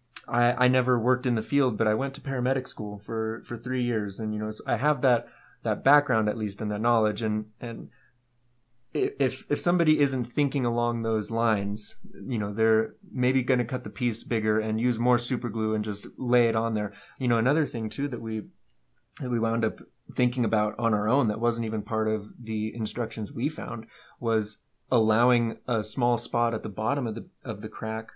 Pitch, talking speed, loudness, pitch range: 115 Hz, 210 wpm, -27 LUFS, 110-125 Hz